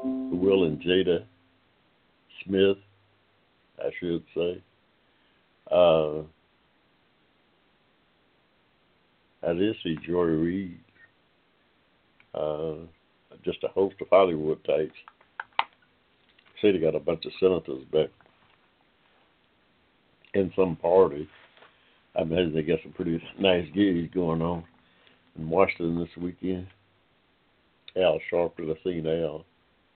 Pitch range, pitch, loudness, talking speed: 80-95 Hz, 85 Hz, -27 LUFS, 100 wpm